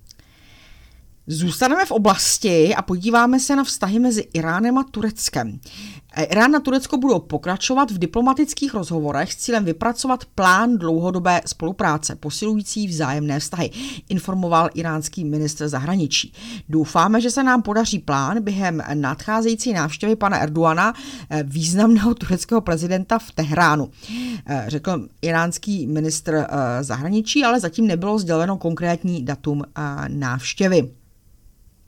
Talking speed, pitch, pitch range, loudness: 115 wpm, 175 Hz, 150-225 Hz, -20 LUFS